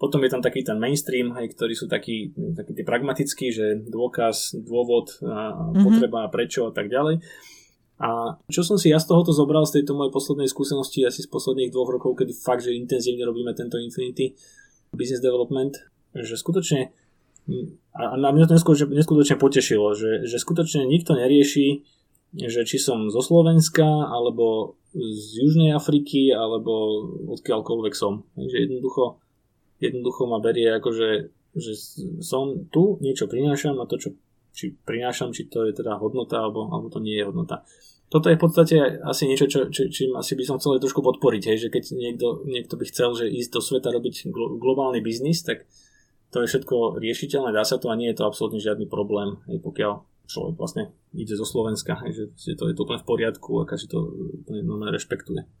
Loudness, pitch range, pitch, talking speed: -23 LUFS, 115-150 Hz, 130 Hz, 175 wpm